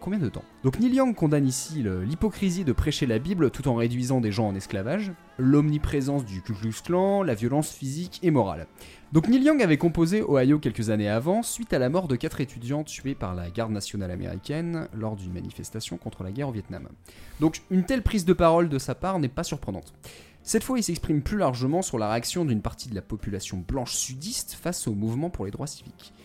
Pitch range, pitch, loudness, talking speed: 110-170 Hz, 135 Hz, -26 LUFS, 220 wpm